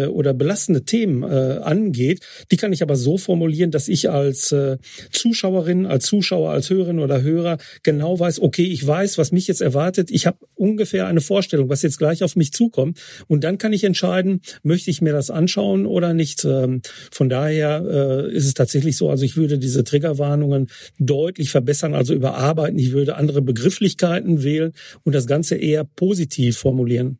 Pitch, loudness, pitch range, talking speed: 155 Hz, -19 LUFS, 140-180 Hz, 170 wpm